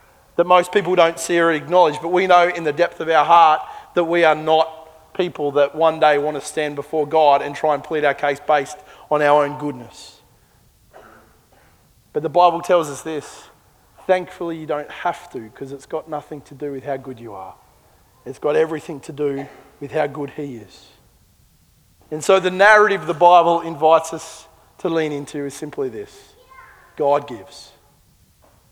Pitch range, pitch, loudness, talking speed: 145-175 Hz, 155 Hz, -18 LUFS, 185 wpm